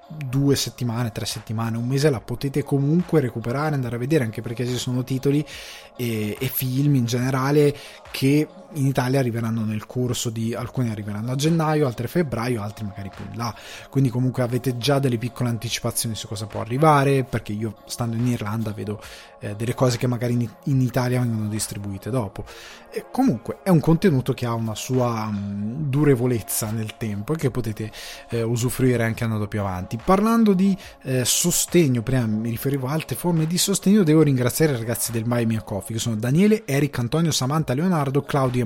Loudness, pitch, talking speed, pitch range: -22 LUFS, 125 Hz, 185 wpm, 115-140 Hz